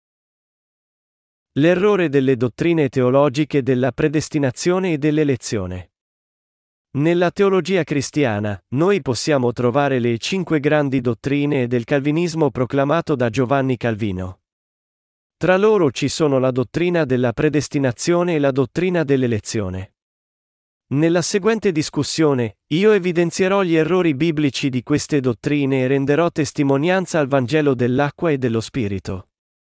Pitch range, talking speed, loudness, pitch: 125-165 Hz, 115 wpm, -18 LUFS, 145 Hz